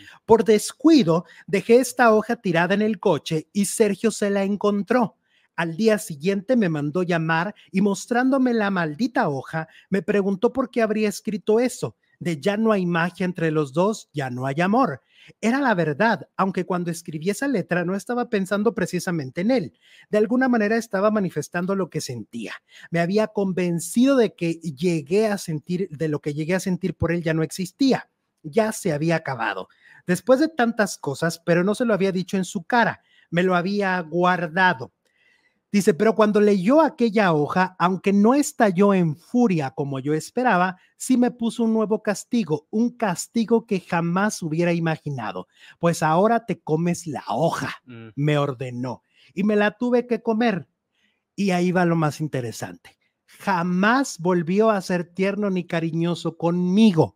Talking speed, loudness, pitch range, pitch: 170 wpm, -22 LUFS, 165-220 Hz, 190 Hz